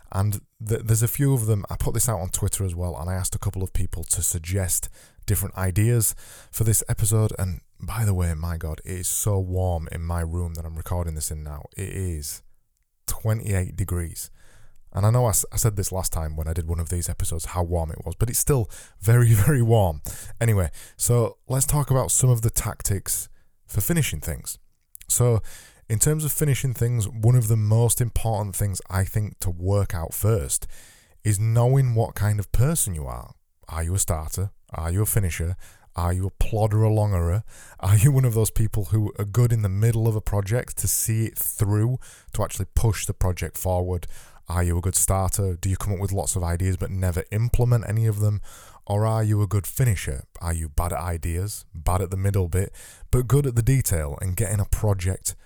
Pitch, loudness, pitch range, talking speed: 100 Hz, -24 LUFS, 90-110 Hz, 215 wpm